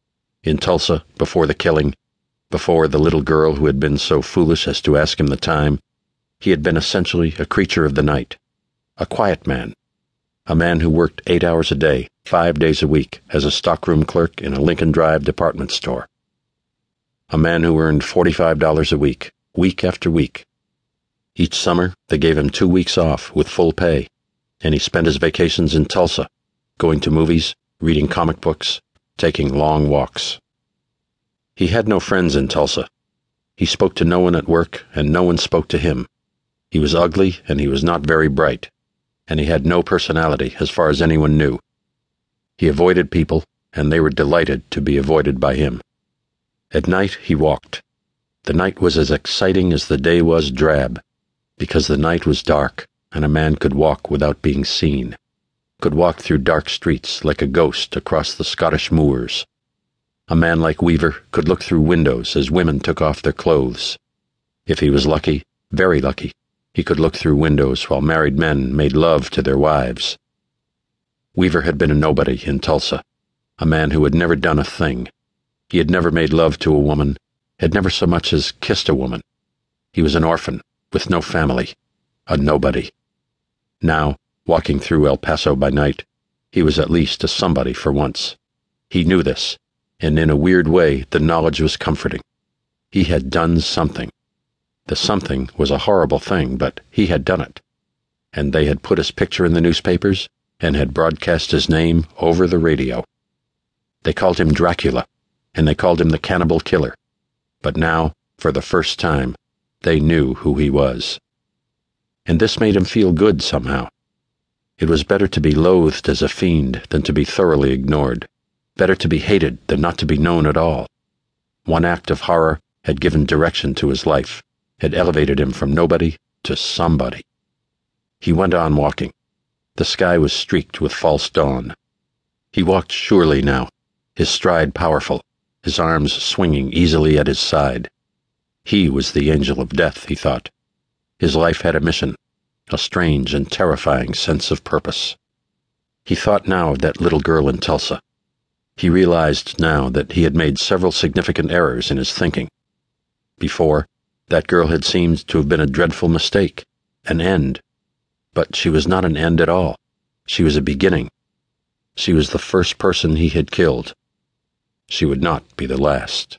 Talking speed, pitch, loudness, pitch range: 175 wpm, 80 Hz, -17 LUFS, 75-85 Hz